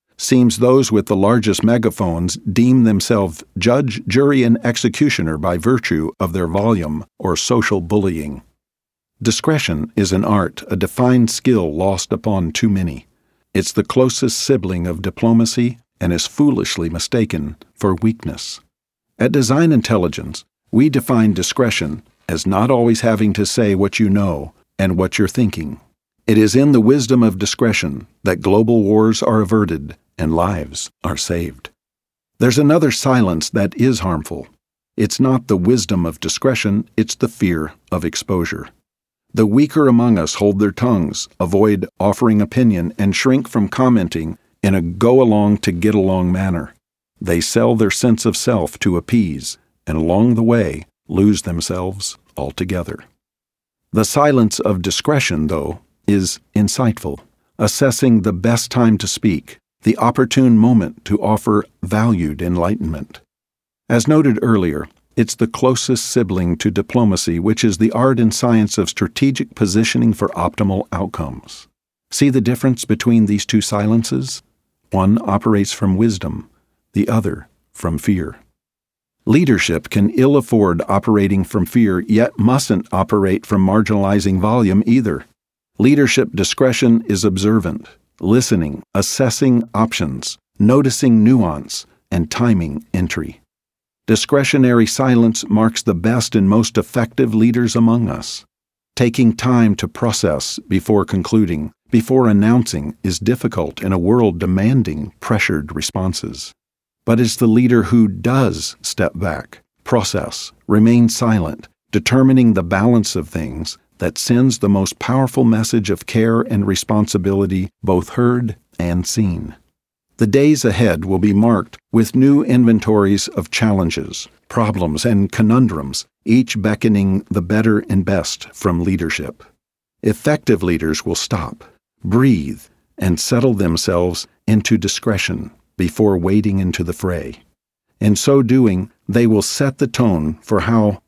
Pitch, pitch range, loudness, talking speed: 110 Hz, 95-120 Hz, -16 LUFS, 135 wpm